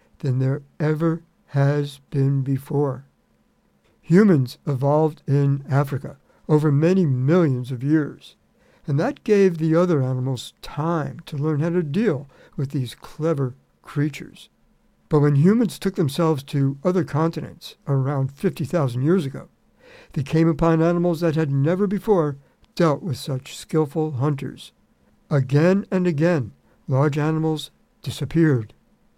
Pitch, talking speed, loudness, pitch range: 155 Hz, 130 wpm, -22 LUFS, 140-170 Hz